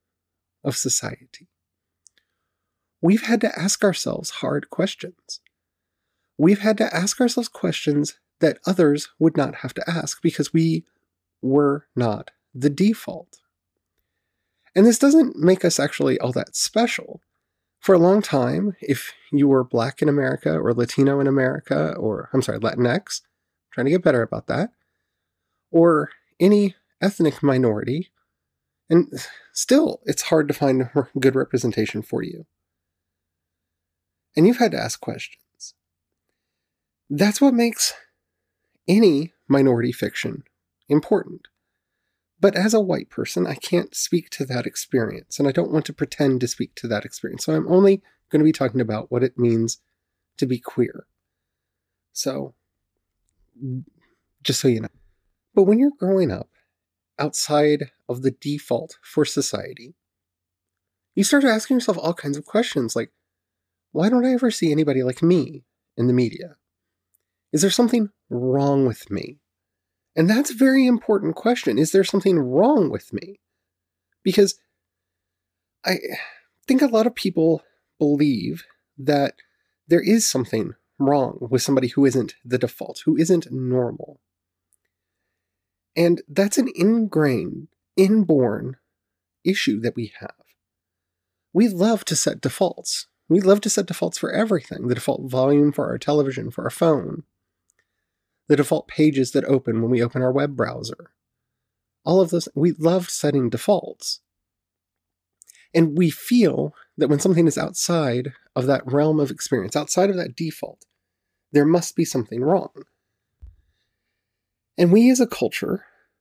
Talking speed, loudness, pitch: 145 wpm, -21 LUFS, 140 Hz